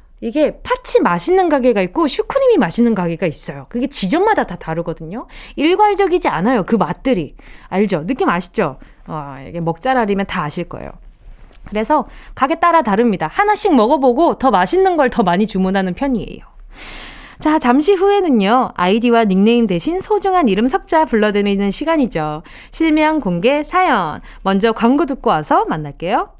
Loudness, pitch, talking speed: -15 LUFS, 240 Hz, 350 characters per minute